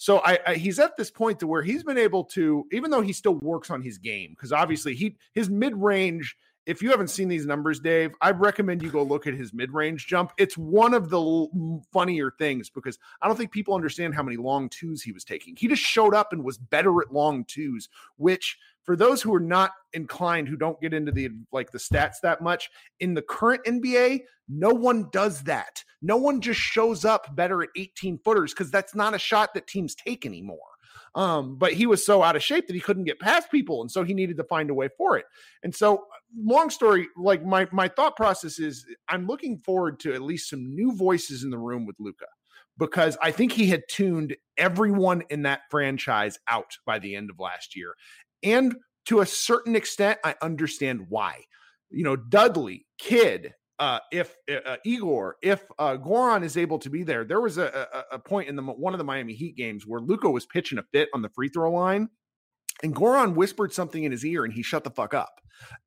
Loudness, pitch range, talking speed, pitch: -25 LUFS, 150-215 Hz, 220 wpm, 180 Hz